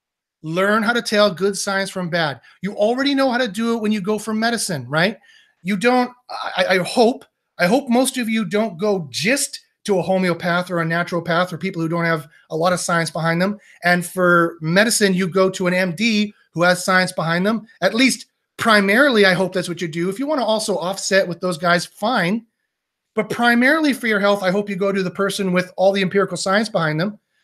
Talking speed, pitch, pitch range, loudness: 225 wpm, 195 Hz, 180-225 Hz, -18 LUFS